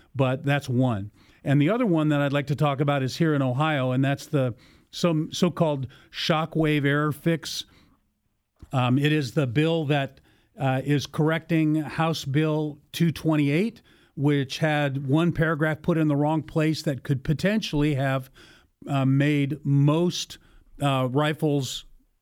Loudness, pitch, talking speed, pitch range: -24 LUFS, 150 Hz, 150 wpm, 135-155 Hz